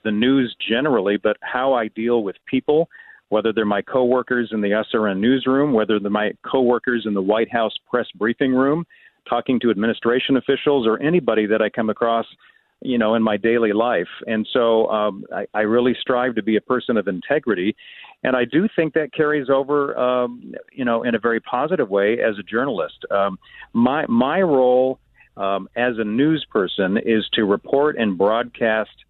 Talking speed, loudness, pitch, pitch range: 190 wpm, -20 LUFS, 115 Hz, 110-130 Hz